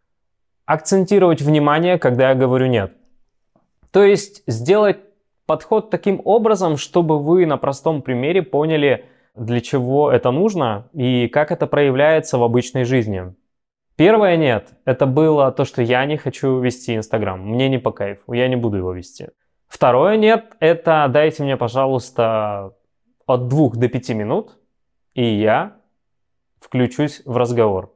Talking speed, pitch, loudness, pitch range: 140 wpm, 135 Hz, -17 LUFS, 120-160 Hz